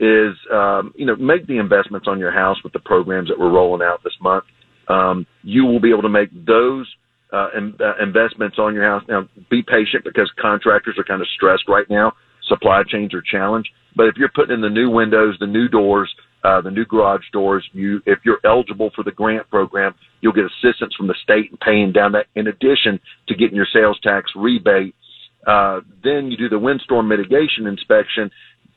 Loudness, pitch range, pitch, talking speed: -16 LUFS, 100-115 Hz, 105 Hz, 205 wpm